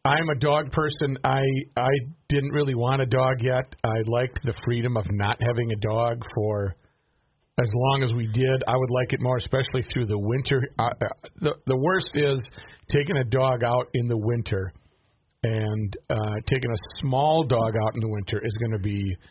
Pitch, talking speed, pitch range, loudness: 125 Hz, 190 wpm, 110-135 Hz, -25 LUFS